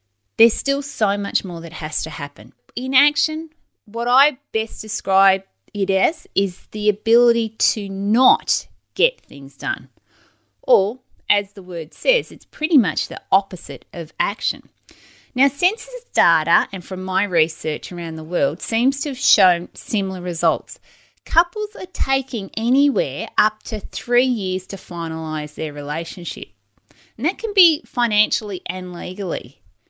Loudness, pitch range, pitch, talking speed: -19 LUFS, 180-270 Hz, 210 Hz, 145 wpm